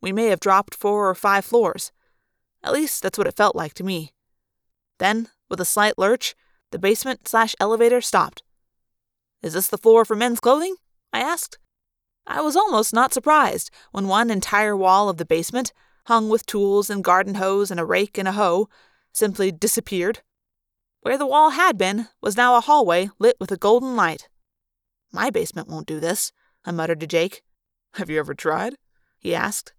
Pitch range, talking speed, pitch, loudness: 185-235 Hz, 185 wpm, 205 Hz, -20 LUFS